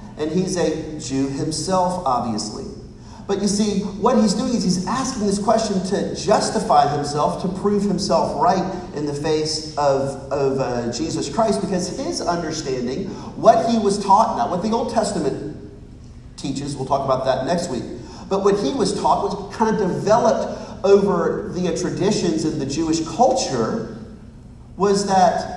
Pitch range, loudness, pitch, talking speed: 155-205 Hz, -20 LUFS, 185 Hz, 160 wpm